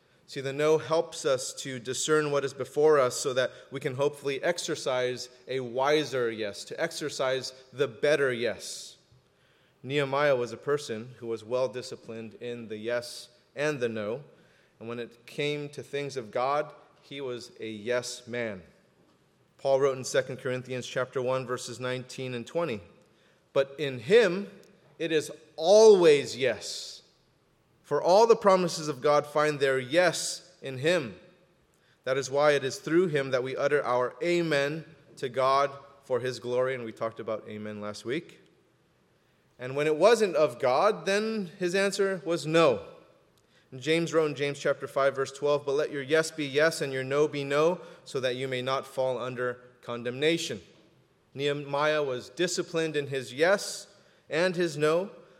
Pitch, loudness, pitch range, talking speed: 140 Hz, -28 LUFS, 125-160 Hz, 165 wpm